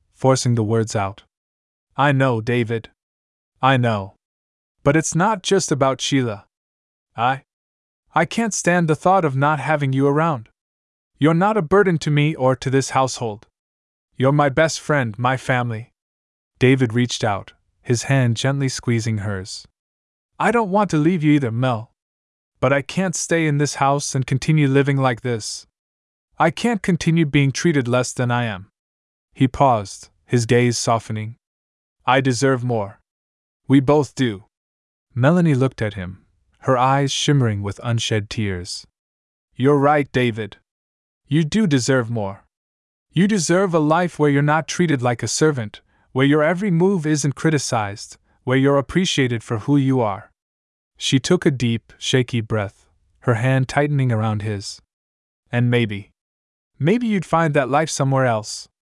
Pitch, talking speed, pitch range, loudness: 125 Hz, 155 wpm, 100-145 Hz, -19 LUFS